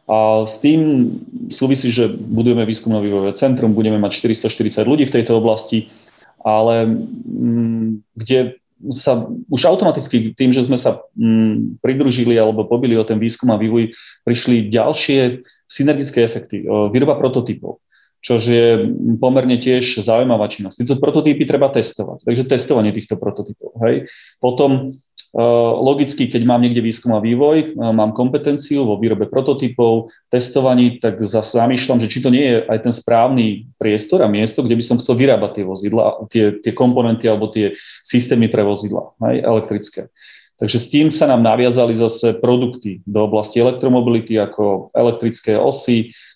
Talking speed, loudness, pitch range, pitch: 145 wpm, -16 LUFS, 110-125 Hz, 115 Hz